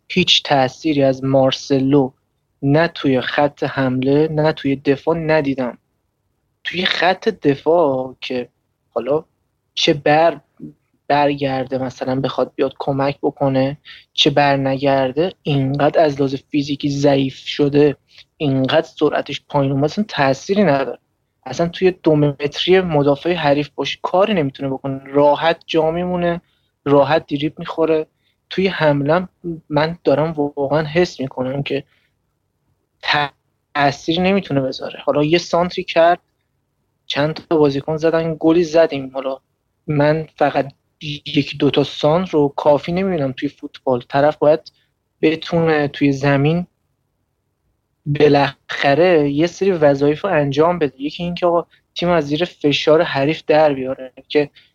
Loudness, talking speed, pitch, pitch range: -17 LUFS, 125 wpm, 145 Hz, 135-160 Hz